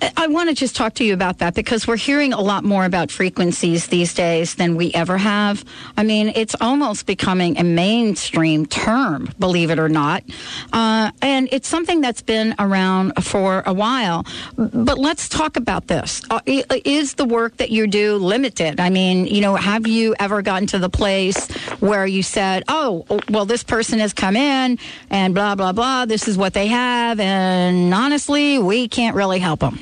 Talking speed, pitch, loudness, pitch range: 190 wpm, 210 Hz, -18 LUFS, 185-240 Hz